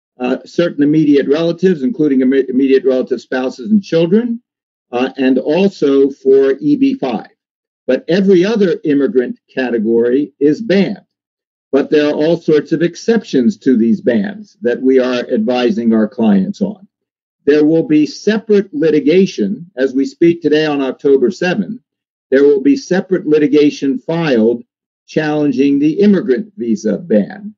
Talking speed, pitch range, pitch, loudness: 135 wpm, 130-200 Hz, 155 Hz, -13 LUFS